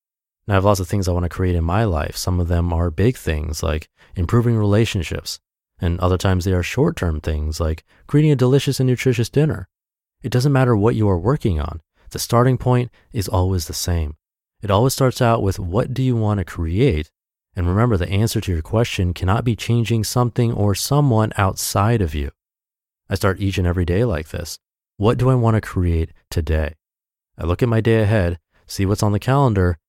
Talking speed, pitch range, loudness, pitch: 210 wpm, 85-115 Hz, -19 LUFS, 100 Hz